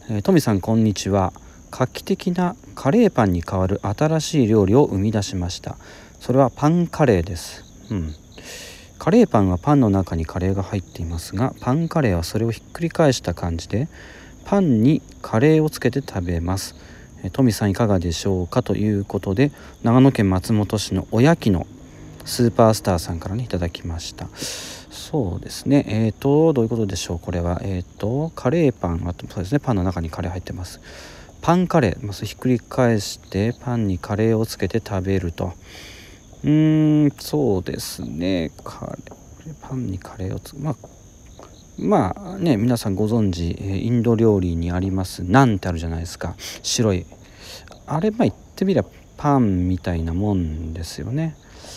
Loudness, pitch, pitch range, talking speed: -21 LUFS, 105 Hz, 90-130 Hz, 355 characters per minute